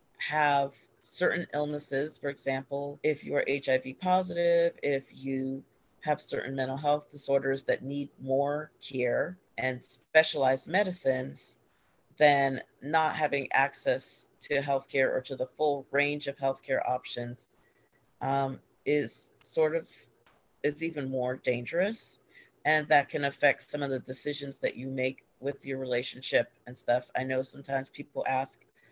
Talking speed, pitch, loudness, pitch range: 140 wpm, 140 Hz, -30 LUFS, 130-150 Hz